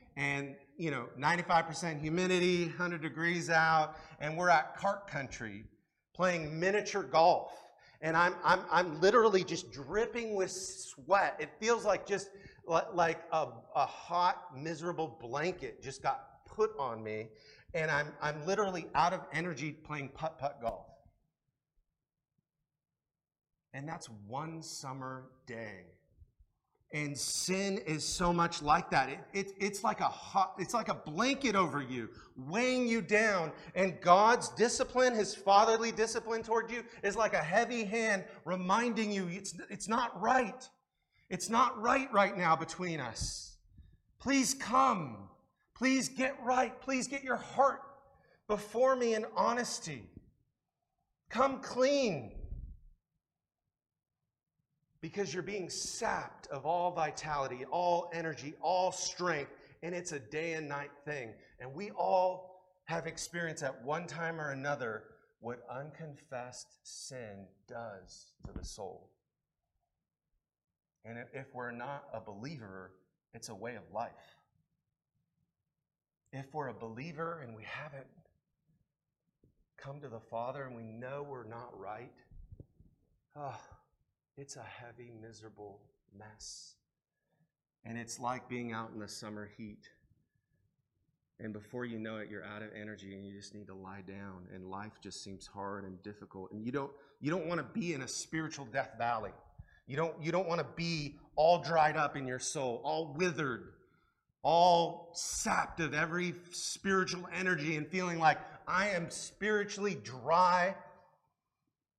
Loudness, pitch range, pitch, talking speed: -34 LUFS, 130-185 Hz, 160 Hz, 140 wpm